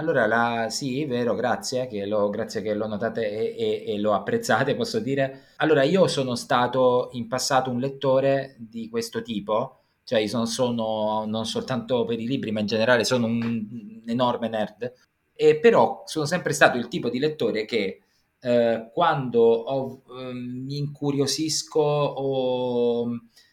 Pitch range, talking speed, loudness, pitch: 115-155 Hz, 160 wpm, -24 LUFS, 130 Hz